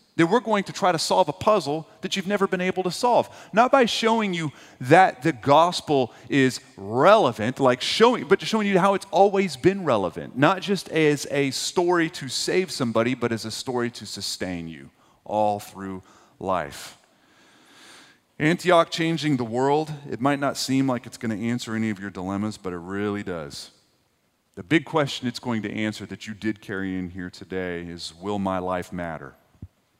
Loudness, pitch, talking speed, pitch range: -23 LUFS, 130 Hz, 190 wpm, 105-175 Hz